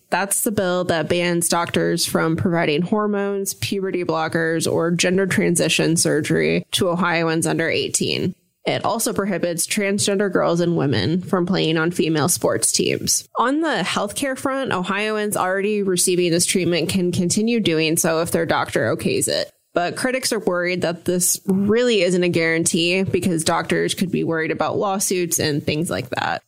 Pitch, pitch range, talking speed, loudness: 180 Hz, 165-200 Hz, 160 wpm, -19 LUFS